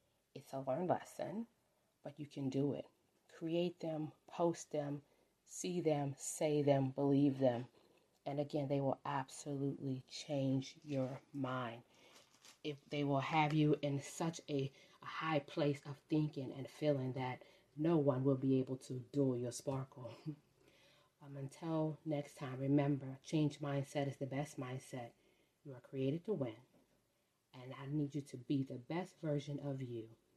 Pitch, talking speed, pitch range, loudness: 145 Hz, 155 wpm, 135-150 Hz, -40 LUFS